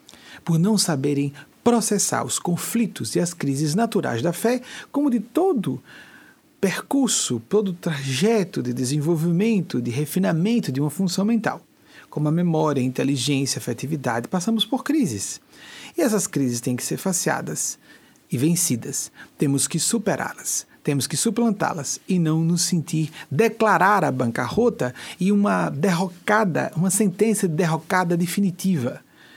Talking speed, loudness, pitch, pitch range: 135 wpm, -22 LUFS, 175 Hz, 145-215 Hz